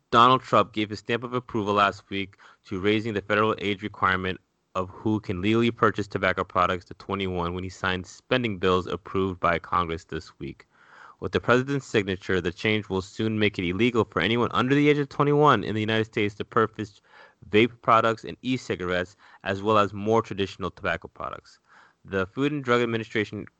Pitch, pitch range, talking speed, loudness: 105 Hz, 95-115 Hz, 190 wpm, -25 LUFS